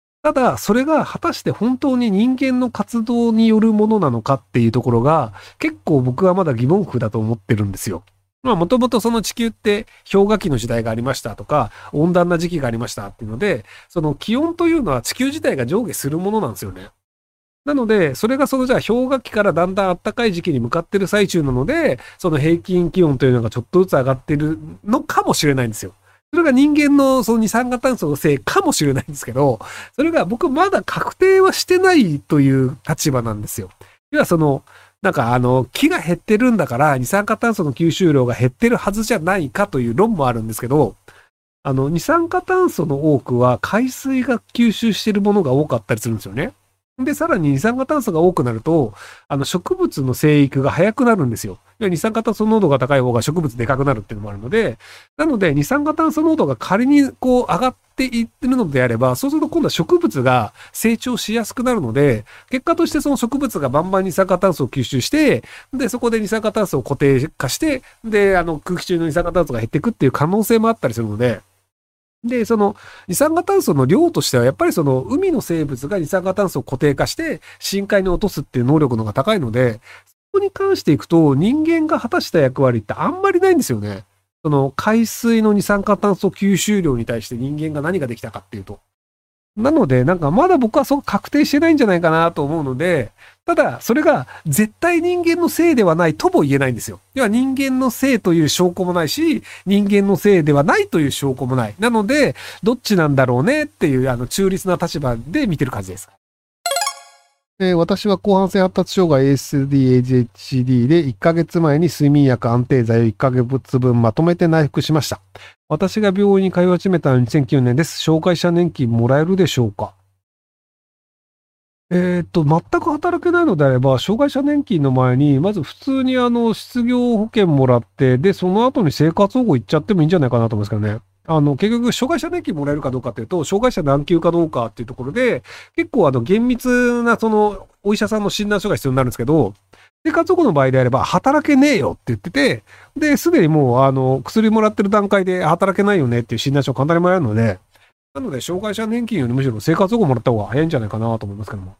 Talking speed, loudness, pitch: 415 characters per minute, -17 LUFS, 175 Hz